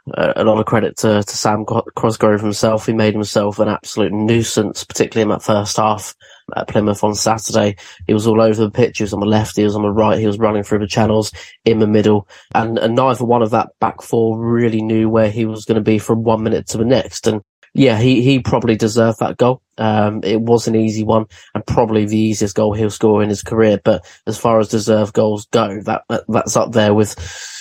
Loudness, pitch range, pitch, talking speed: -15 LUFS, 105-115 Hz, 110 Hz, 235 wpm